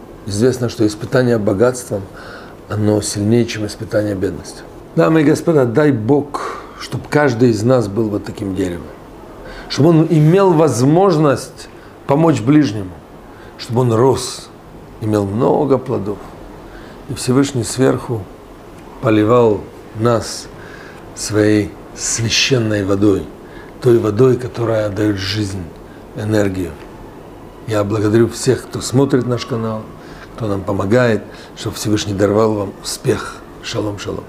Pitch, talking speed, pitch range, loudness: 110 Hz, 115 wpm, 105-130 Hz, -16 LUFS